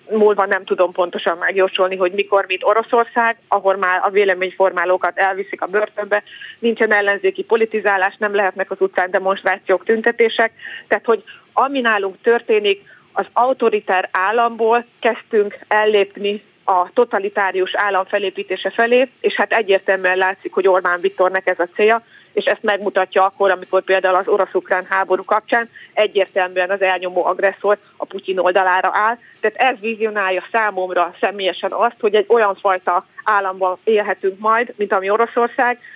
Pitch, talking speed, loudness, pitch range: 200 Hz, 140 wpm, -17 LUFS, 185-225 Hz